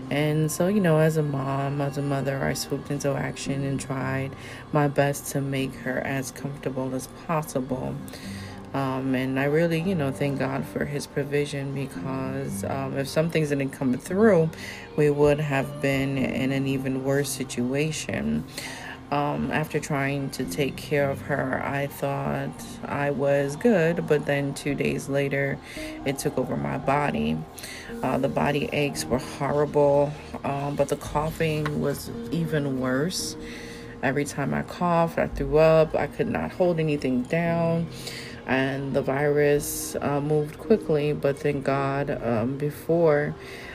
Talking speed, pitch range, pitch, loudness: 155 wpm, 135-150 Hz, 140 Hz, -26 LUFS